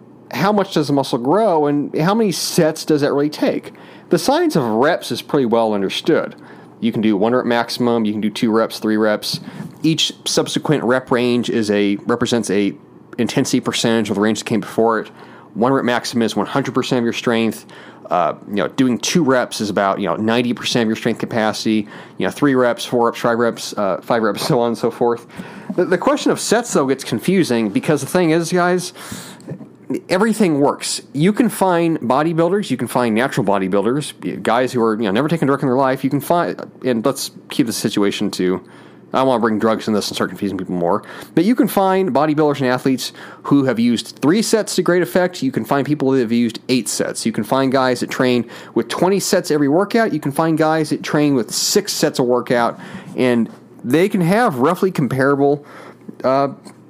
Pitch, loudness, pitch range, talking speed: 130 Hz, -17 LUFS, 115-165 Hz, 210 wpm